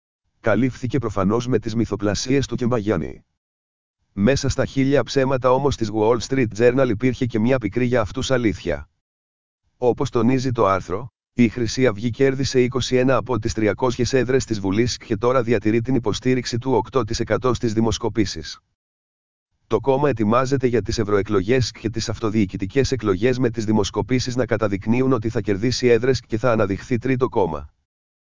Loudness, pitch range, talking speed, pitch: -21 LUFS, 105-130 Hz, 150 wpm, 115 Hz